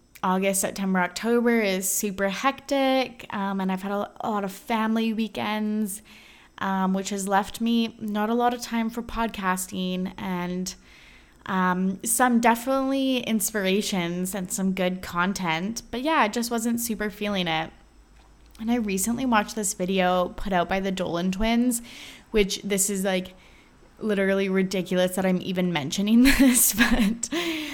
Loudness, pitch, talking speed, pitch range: -25 LUFS, 205 Hz, 145 wpm, 190-230 Hz